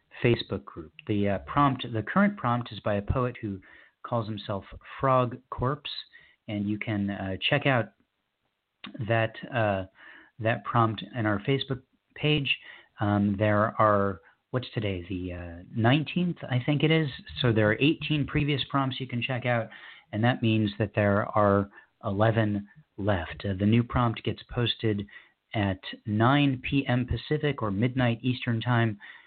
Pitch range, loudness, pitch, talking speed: 105-130 Hz, -28 LUFS, 115 Hz, 155 wpm